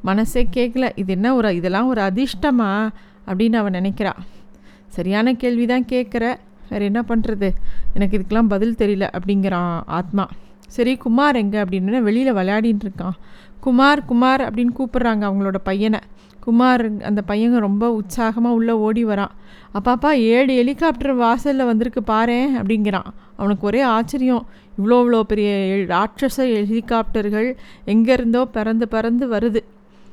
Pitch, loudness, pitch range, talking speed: 225 Hz, -18 LUFS, 205-245 Hz, 125 wpm